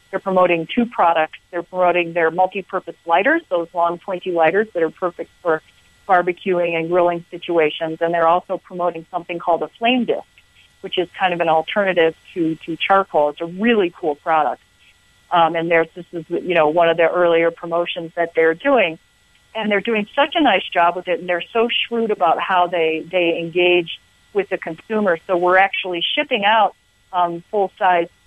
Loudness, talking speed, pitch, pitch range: -18 LUFS, 185 wpm, 175 Hz, 165-185 Hz